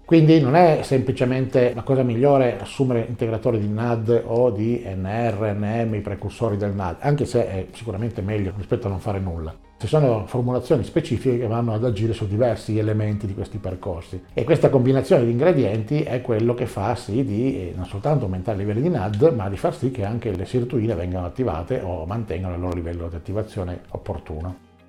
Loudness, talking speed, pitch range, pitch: -22 LUFS, 190 wpm, 100-125 Hz, 115 Hz